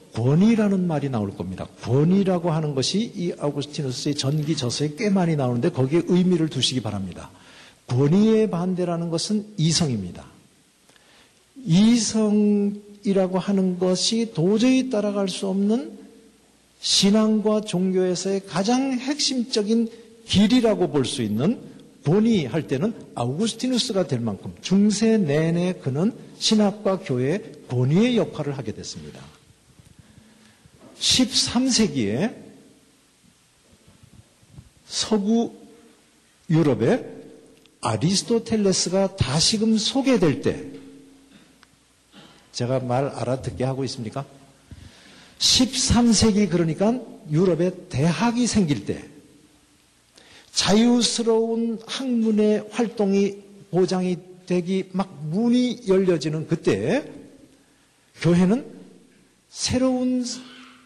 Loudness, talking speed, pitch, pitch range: -22 LUFS, 225 characters per minute, 190 Hz, 150-220 Hz